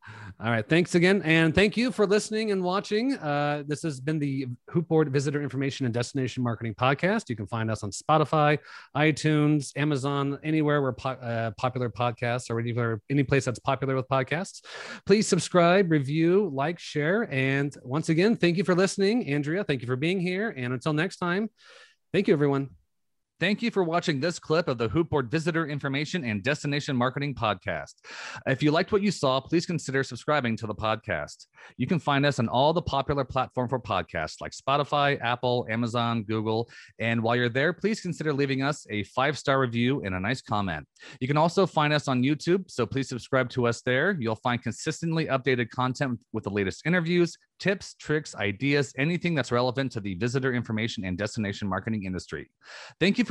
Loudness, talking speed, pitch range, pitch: -27 LUFS, 190 wpm, 120-165 Hz, 140 Hz